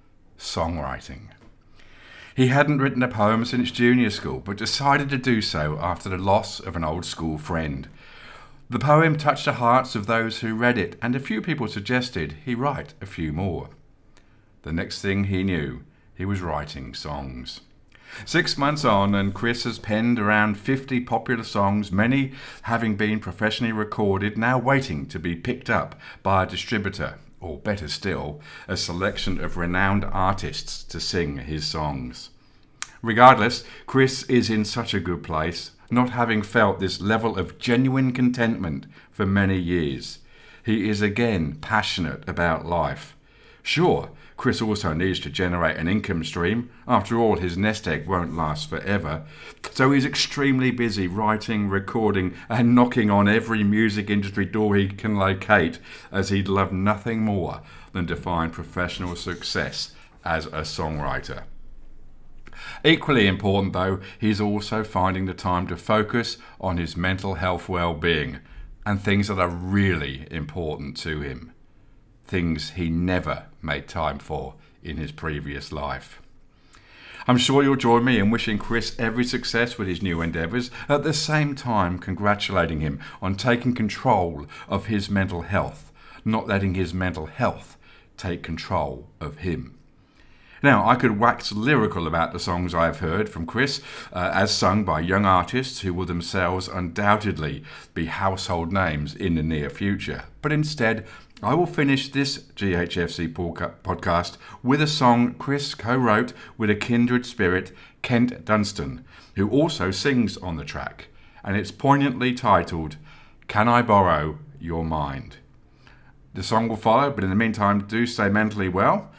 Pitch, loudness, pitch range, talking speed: 100 Hz, -23 LUFS, 85-115 Hz, 155 wpm